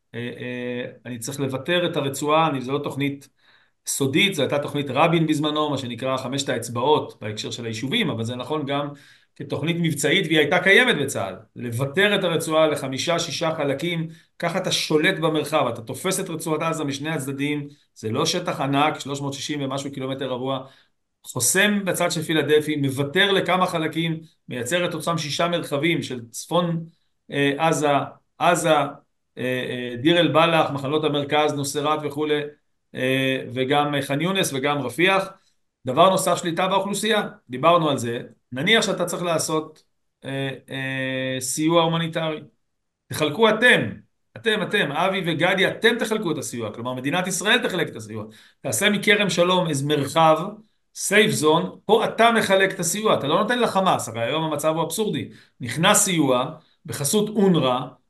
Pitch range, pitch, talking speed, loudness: 135-175 Hz, 155 Hz, 145 wpm, -22 LUFS